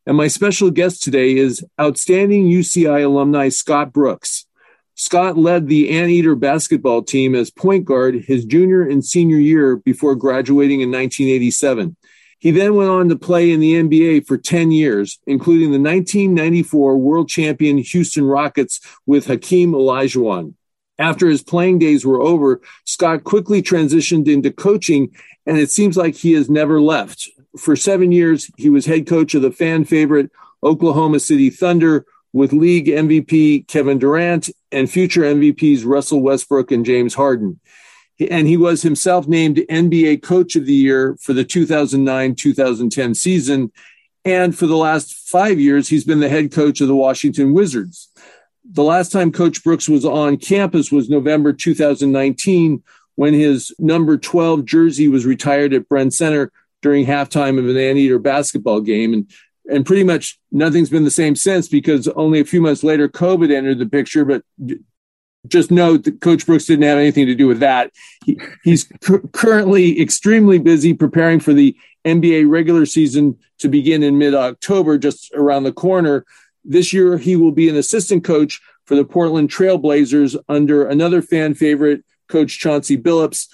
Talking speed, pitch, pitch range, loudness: 160 wpm, 155 Hz, 140-170 Hz, -14 LUFS